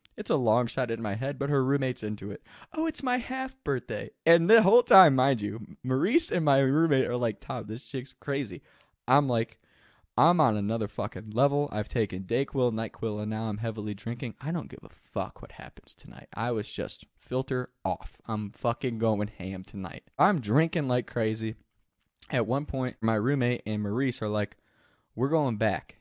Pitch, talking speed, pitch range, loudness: 120 Hz, 190 wpm, 105-140 Hz, -28 LUFS